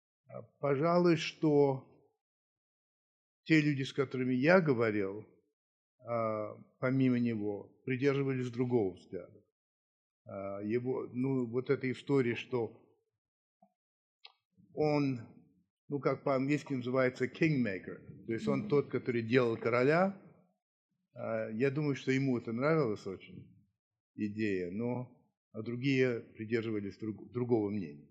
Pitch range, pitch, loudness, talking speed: 110-140 Hz, 125 Hz, -33 LUFS, 95 wpm